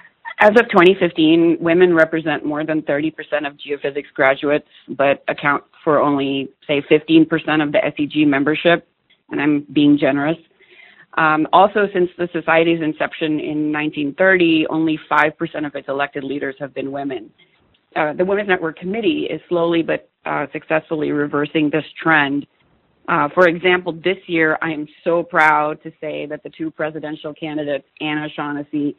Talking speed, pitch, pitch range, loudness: 150 wpm, 155 Hz, 145-165 Hz, -18 LUFS